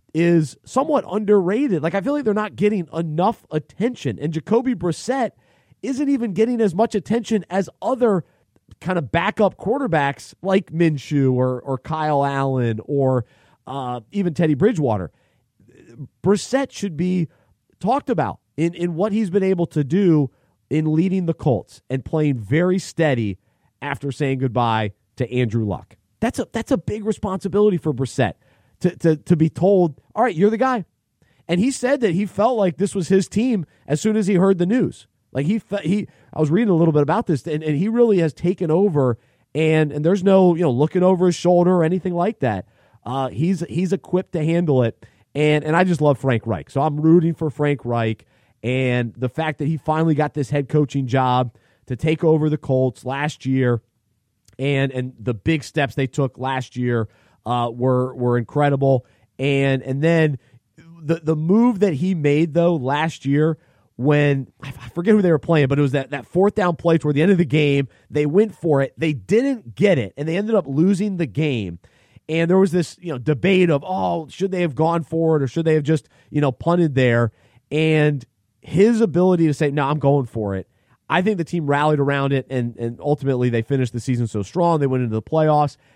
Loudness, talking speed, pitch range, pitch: -20 LUFS, 200 wpm, 130-180 Hz, 155 Hz